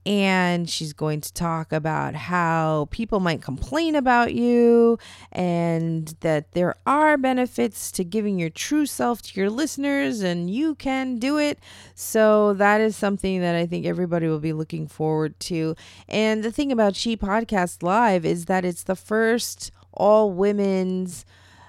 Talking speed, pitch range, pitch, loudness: 160 wpm, 165-230 Hz, 190 Hz, -22 LUFS